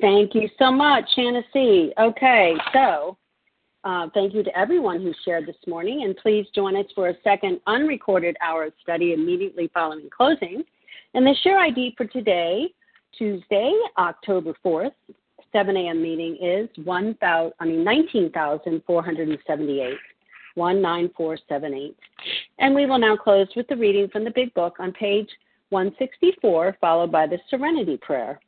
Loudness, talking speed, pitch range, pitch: -21 LUFS, 145 wpm, 170-260 Hz, 200 Hz